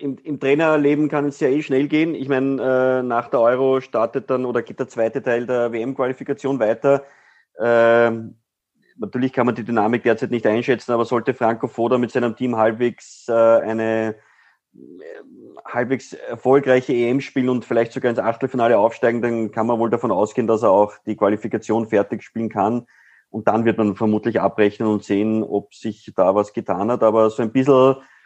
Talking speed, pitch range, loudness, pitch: 185 wpm, 110-130 Hz, -19 LUFS, 120 Hz